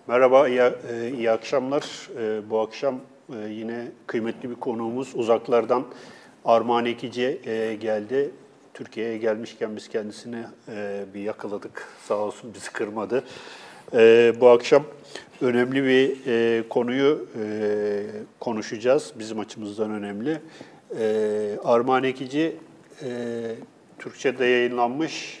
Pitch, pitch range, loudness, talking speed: 115 Hz, 110-125 Hz, -24 LUFS, 85 wpm